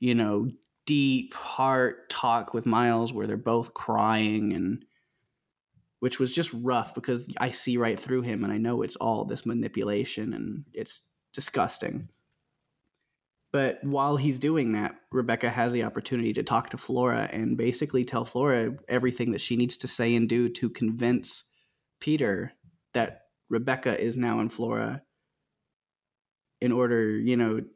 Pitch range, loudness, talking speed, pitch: 115-125 Hz, -28 LUFS, 150 wpm, 120 Hz